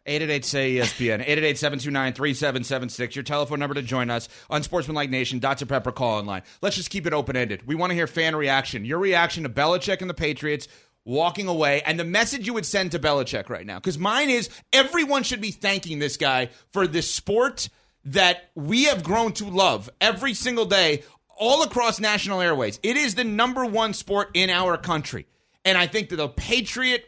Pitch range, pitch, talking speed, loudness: 140-205 Hz, 170 Hz, 200 wpm, -23 LUFS